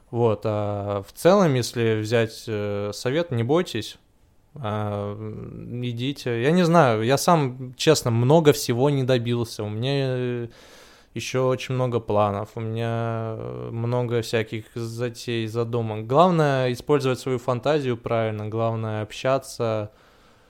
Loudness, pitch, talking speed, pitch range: -23 LUFS, 120 Hz, 115 wpm, 110-130 Hz